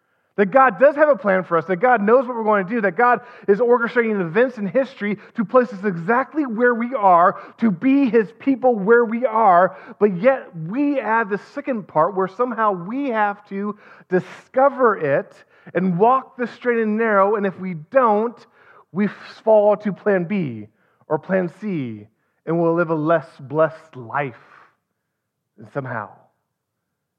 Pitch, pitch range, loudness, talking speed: 210 Hz, 180-245 Hz, -19 LUFS, 170 wpm